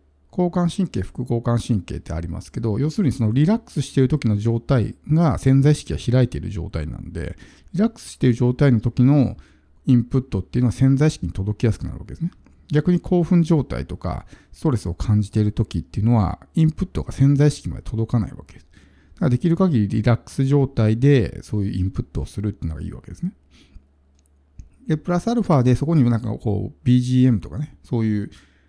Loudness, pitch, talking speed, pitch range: -21 LUFS, 120 Hz, 435 characters per minute, 100-145 Hz